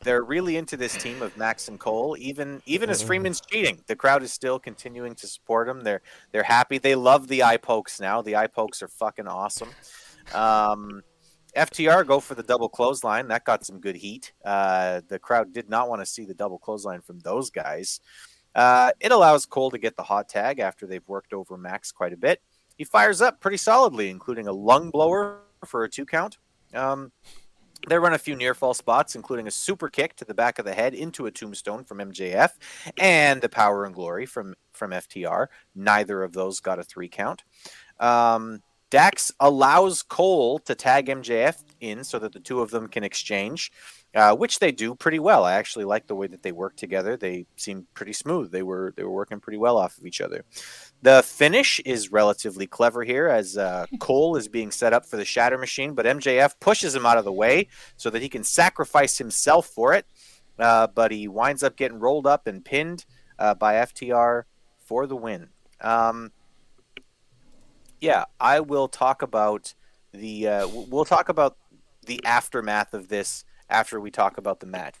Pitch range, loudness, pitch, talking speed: 105-135 Hz, -22 LUFS, 120 Hz, 200 wpm